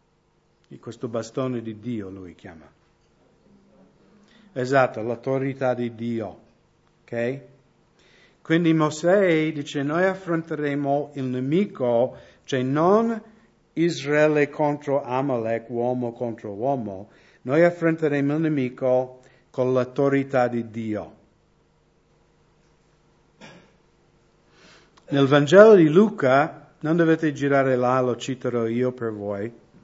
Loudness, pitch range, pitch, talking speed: -22 LUFS, 120-160 Hz, 140 Hz, 95 wpm